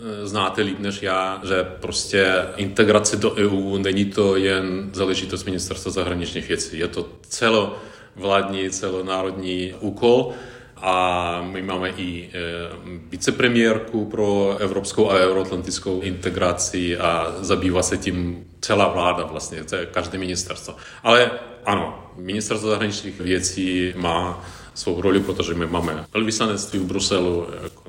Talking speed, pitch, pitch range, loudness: 125 wpm, 95 Hz, 90-100 Hz, -22 LUFS